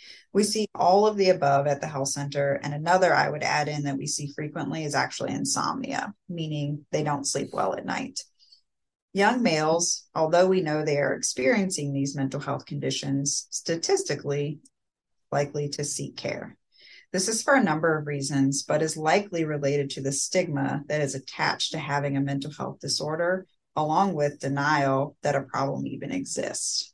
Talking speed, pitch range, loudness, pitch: 175 wpm, 140-175 Hz, -26 LUFS, 150 Hz